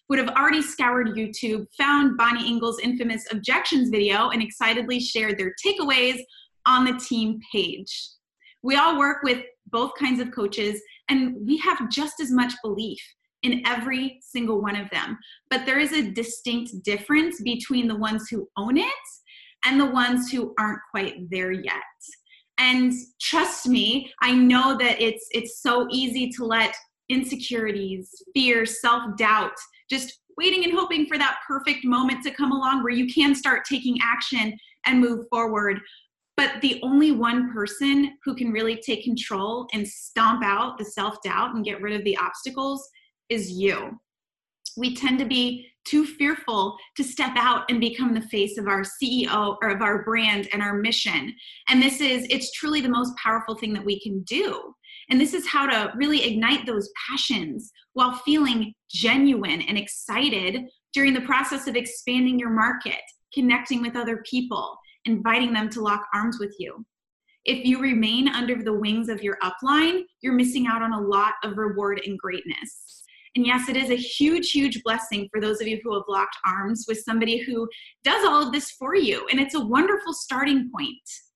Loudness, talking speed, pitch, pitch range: -23 LUFS, 175 wpm, 245 Hz, 220-270 Hz